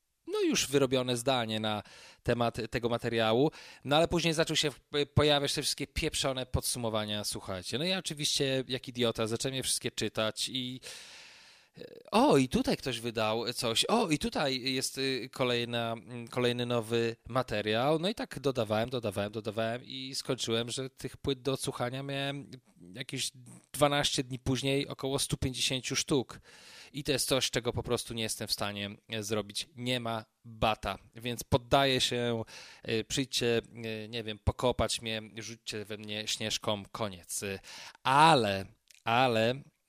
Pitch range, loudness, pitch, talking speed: 110-135 Hz, -31 LUFS, 120 Hz, 140 wpm